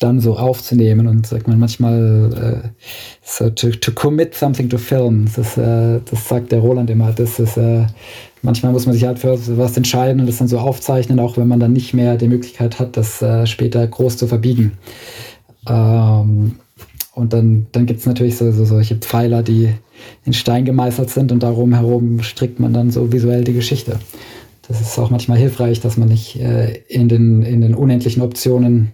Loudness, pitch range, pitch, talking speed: -15 LUFS, 115-125 Hz, 120 Hz, 195 wpm